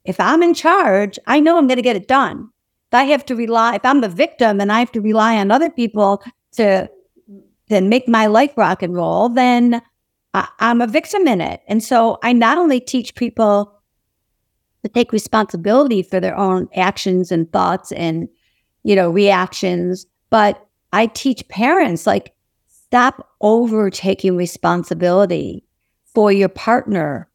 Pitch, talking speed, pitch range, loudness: 220 Hz, 160 wpm, 195-245 Hz, -15 LUFS